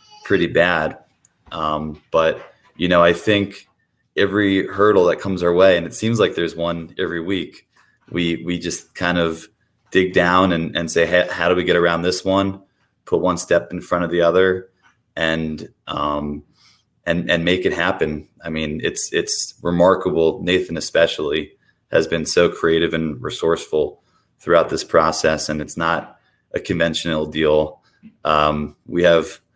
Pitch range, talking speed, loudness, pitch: 80-95 Hz, 160 wpm, -18 LUFS, 85 Hz